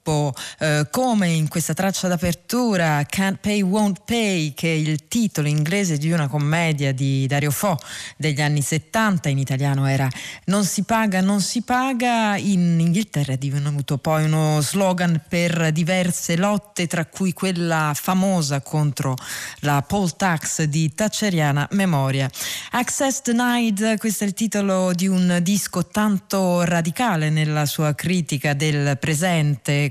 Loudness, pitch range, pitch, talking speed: -21 LUFS, 150-200 Hz, 170 Hz, 140 wpm